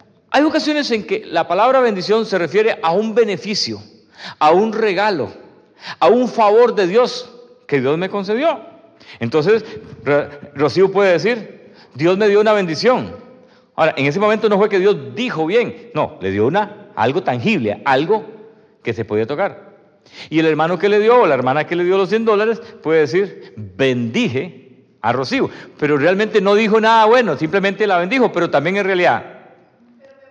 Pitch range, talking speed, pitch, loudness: 160-225 Hz, 170 wpm, 205 Hz, -16 LUFS